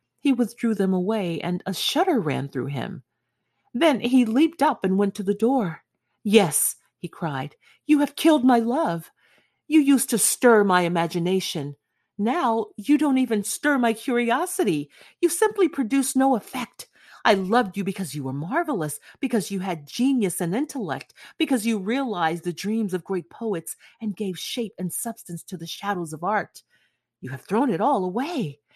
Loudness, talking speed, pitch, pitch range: -23 LUFS, 170 wpm, 215 Hz, 175-260 Hz